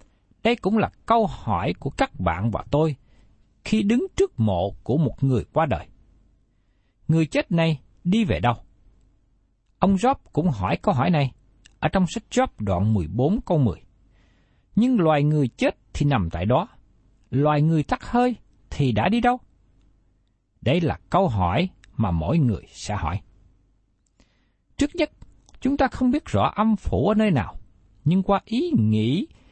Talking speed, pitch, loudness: 165 wpm, 125 Hz, -23 LUFS